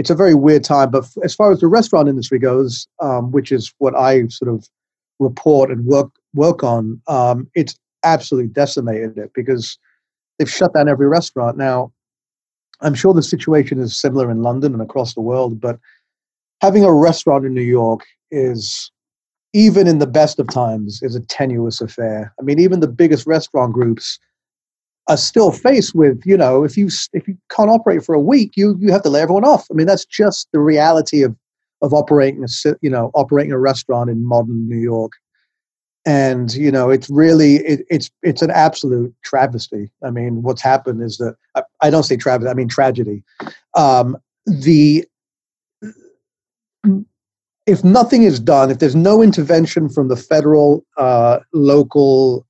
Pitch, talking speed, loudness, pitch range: 140 Hz, 175 wpm, -14 LUFS, 125-165 Hz